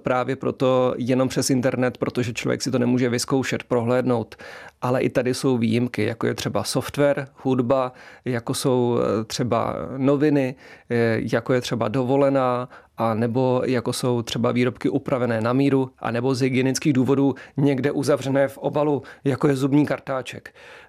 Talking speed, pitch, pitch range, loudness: 150 wpm, 130 Hz, 125-135 Hz, -22 LUFS